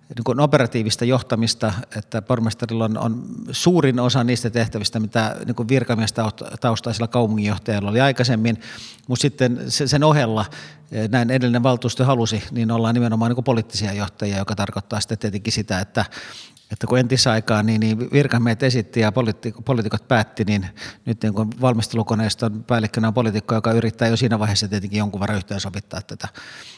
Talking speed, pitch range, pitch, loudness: 145 wpm, 110-125 Hz, 115 Hz, -20 LUFS